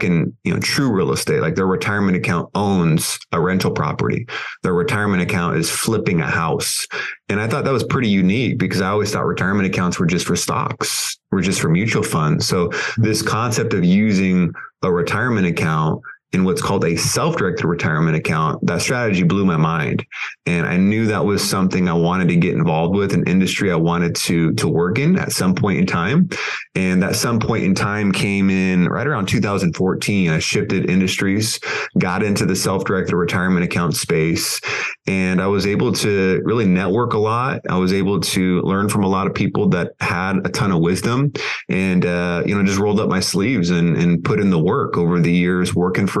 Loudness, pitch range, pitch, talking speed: -18 LUFS, 90-100 Hz, 95 Hz, 200 wpm